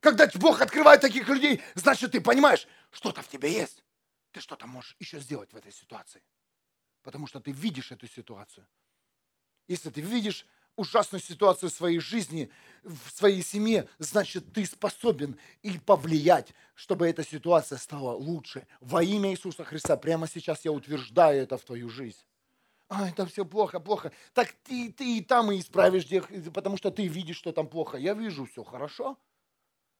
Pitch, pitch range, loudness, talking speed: 180 Hz, 155-210 Hz, -26 LUFS, 165 wpm